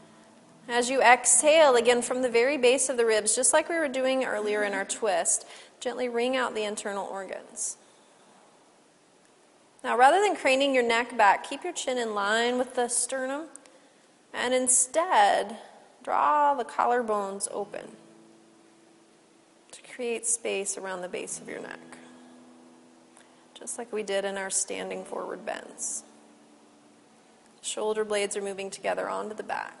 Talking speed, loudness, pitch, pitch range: 145 wpm, -26 LUFS, 235 Hz, 195-255 Hz